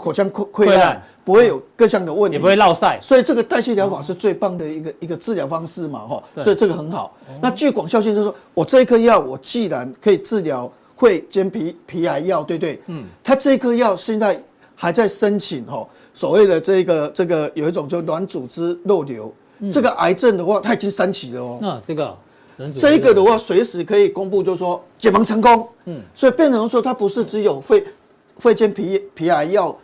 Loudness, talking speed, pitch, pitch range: -17 LUFS, 315 characters per minute, 200 Hz, 175-230 Hz